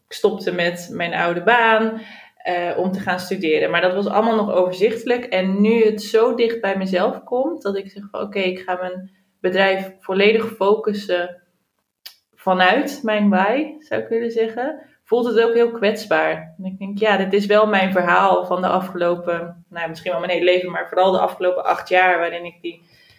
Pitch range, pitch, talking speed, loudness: 180-220 Hz, 190 Hz, 195 wpm, -19 LUFS